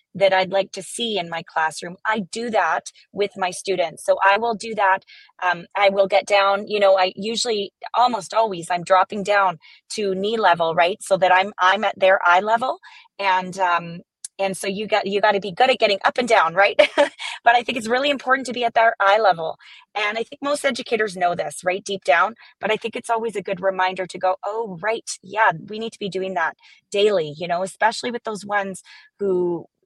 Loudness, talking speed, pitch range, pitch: -20 LUFS, 225 wpm, 185-225 Hz, 200 Hz